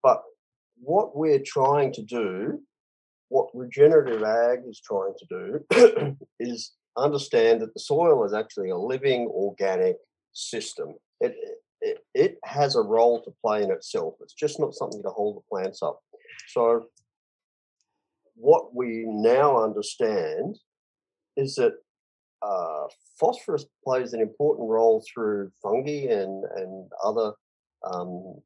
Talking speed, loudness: 130 wpm, -25 LUFS